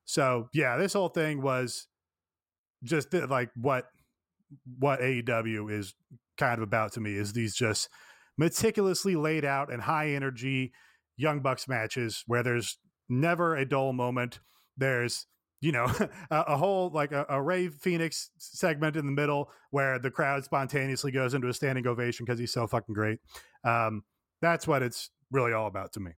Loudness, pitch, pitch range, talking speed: -30 LUFS, 130 Hz, 120-155 Hz, 170 wpm